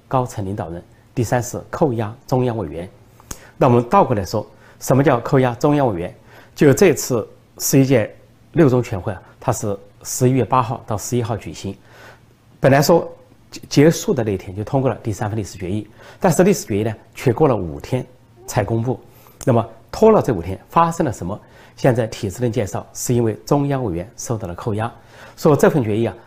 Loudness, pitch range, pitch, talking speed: -19 LUFS, 110-130 Hz, 120 Hz, 285 characters per minute